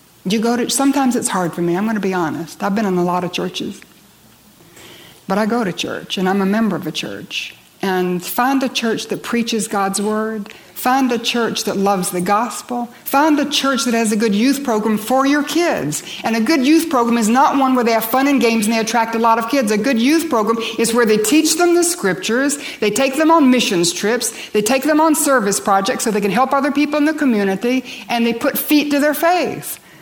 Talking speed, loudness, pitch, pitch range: 240 wpm, -16 LUFS, 235 Hz, 210-275 Hz